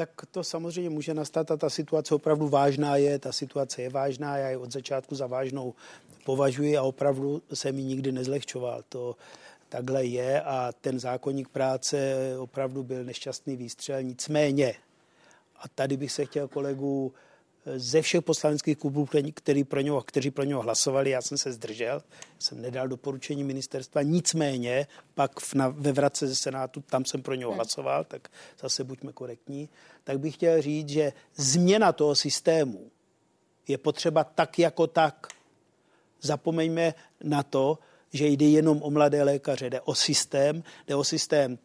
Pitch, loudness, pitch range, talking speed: 140 Hz, -28 LUFS, 135-150 Hz, 155 wpm